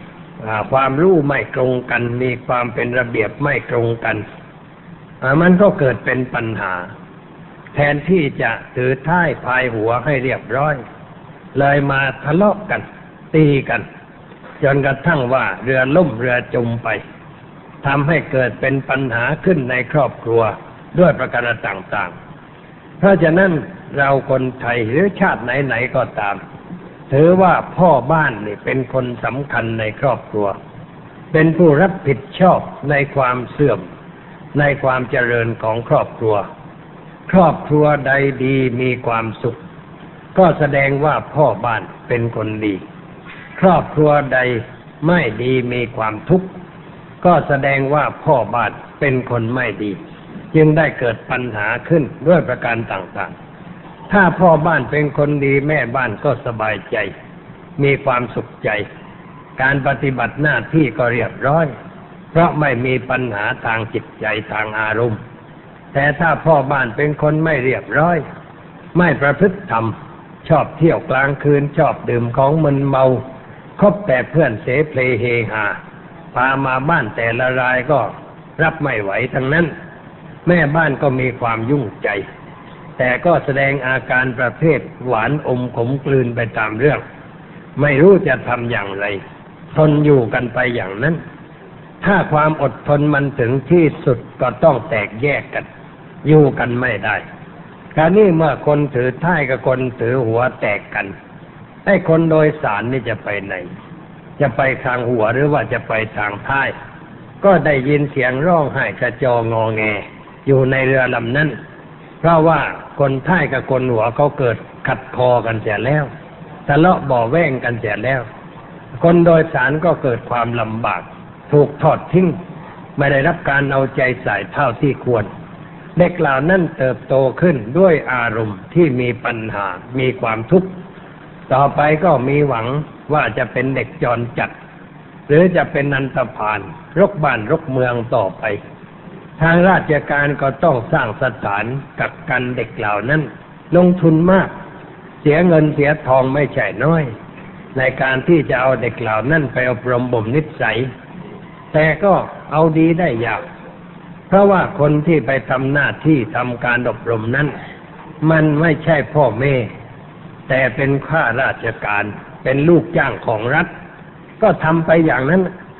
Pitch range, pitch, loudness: 125-165 Hz, 145 Hz, -16 LUFS